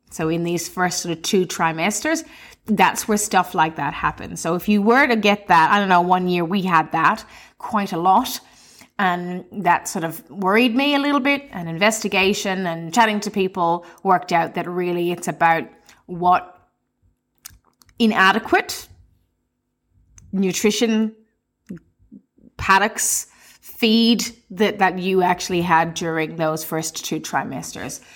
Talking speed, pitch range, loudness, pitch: 145 wpm, 170-215 Hz, -19 LUFS, 185 Hz